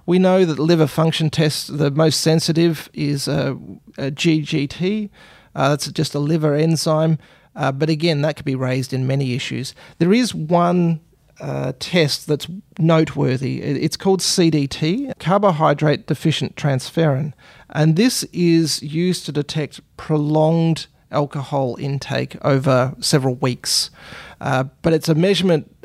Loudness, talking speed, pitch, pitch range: -19 LUFS, 135 wpm, 155 Hz, 140-165 Hz